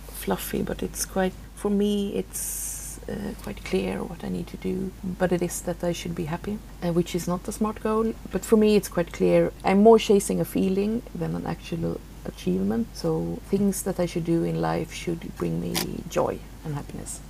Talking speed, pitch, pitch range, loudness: 205 wpm, 185 Hz, 170-205 Hz, -26 LUFS